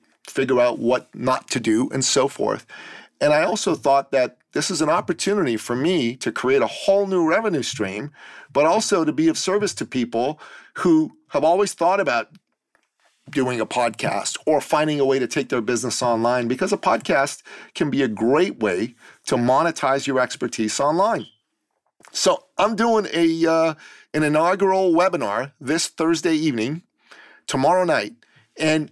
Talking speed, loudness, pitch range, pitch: 165 wpm, -21 LUFS, 130-190 Hz, 160 Hz